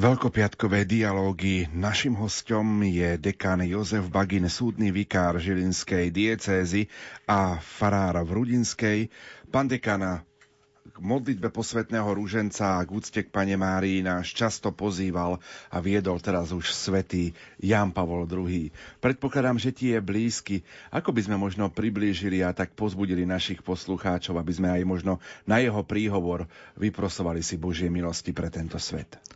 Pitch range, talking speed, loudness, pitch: 90-105 Hz, 140 wpm, -27 LUFS, 95 Hz